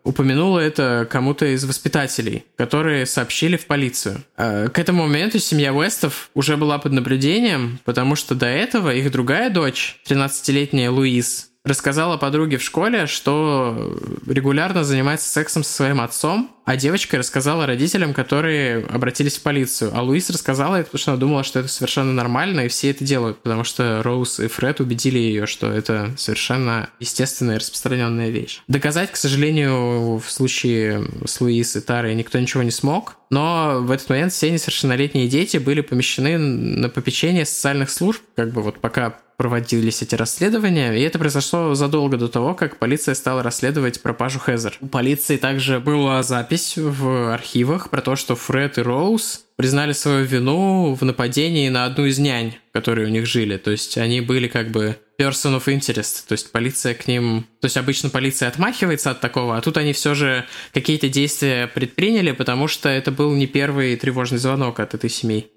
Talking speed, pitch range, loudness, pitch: 170 wpm, 120-150 Hz, -19 LUFS, 135 Hz